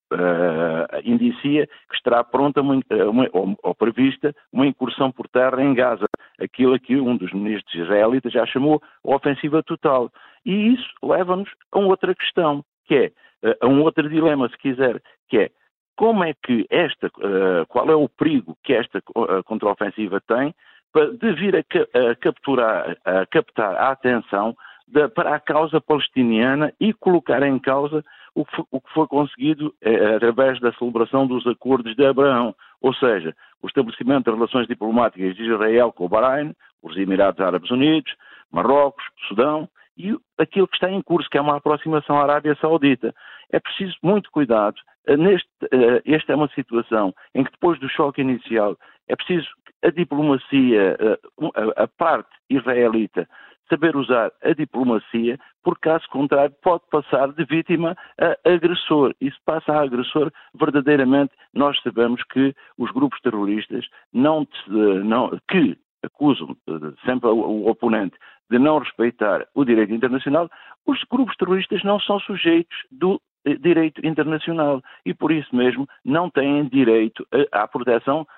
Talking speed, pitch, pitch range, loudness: 150 wpm, 145 Hz, 120-160 Hz, -20 LUFS